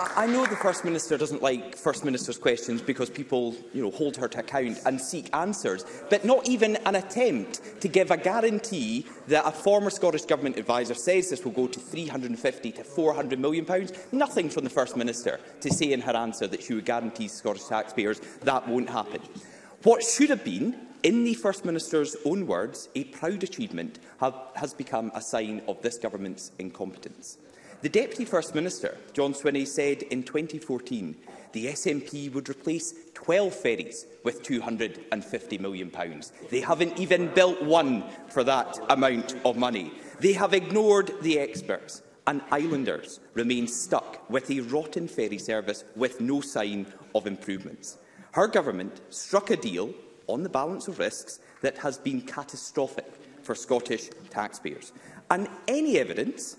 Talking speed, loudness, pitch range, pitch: 165 wpm, -28 LUFS, 125-195 Hz, 150 Hz